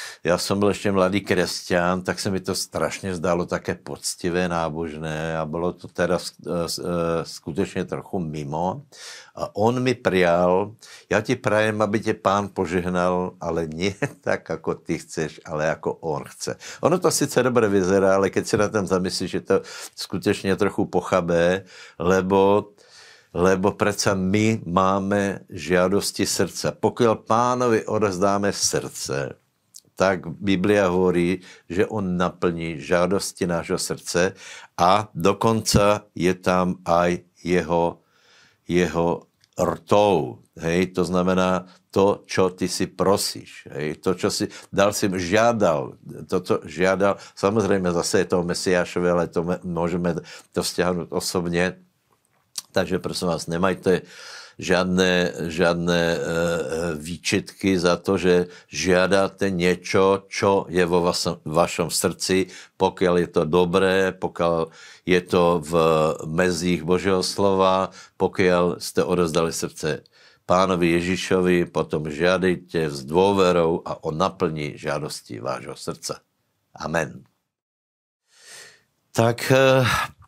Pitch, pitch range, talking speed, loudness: 90 Hz, 85-100 Hz, 125 wpm, -22 LUFS